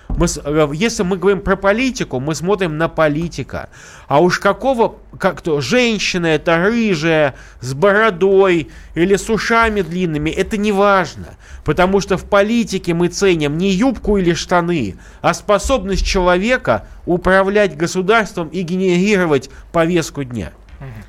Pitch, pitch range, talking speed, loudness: 180 Hz, 160-200 Hz, 130 wpm, -16 LUFS